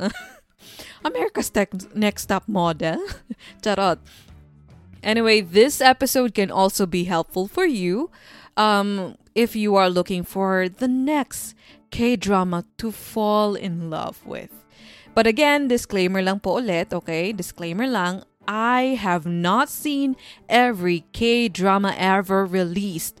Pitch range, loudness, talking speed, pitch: 180-230 Hz, -21 LUFS, 120 wpm, 195 Hz